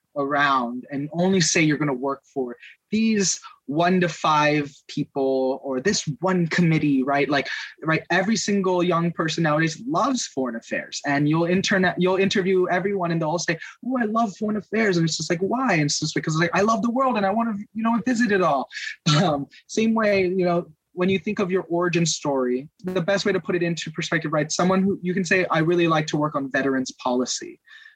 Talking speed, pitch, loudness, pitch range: 220 wpm, 175 Hz, -22 LUFS, 150-195 Hz